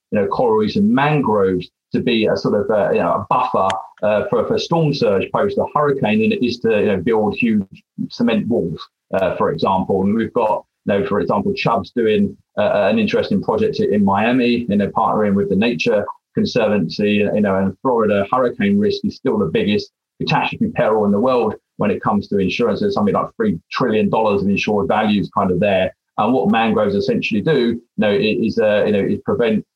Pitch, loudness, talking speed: 155 Hz, -17 LUFS, 205 wpm